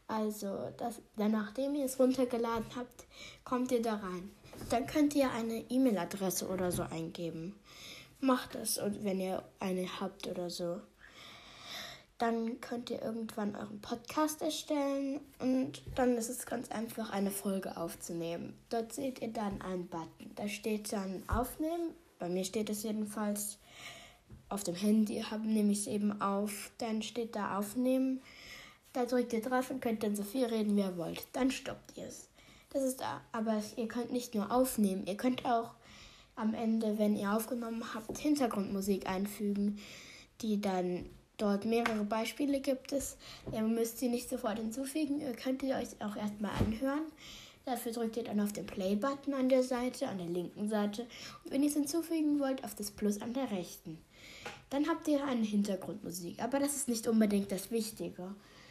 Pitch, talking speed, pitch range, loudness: 225 Hz, 170 wpm, 200-255 Hz, -36 LUFS